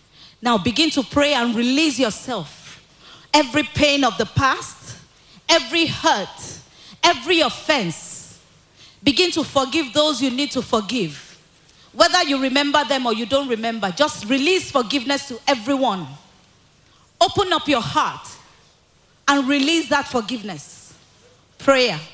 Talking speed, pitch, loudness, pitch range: 125 wpm, 275 Hz, -19 LUFS, 235-300 Hz